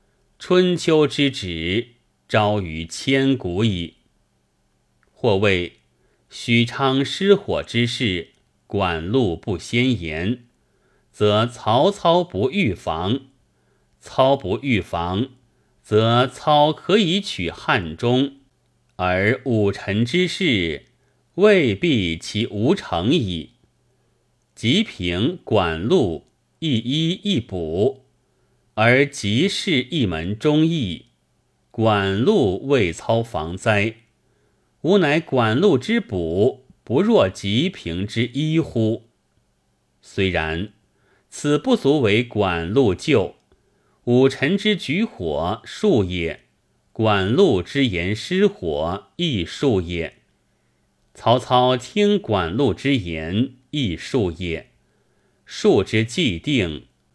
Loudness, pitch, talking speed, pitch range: -20 LUFS, 120 Hz, 130 characters per minute, 95-140 Hz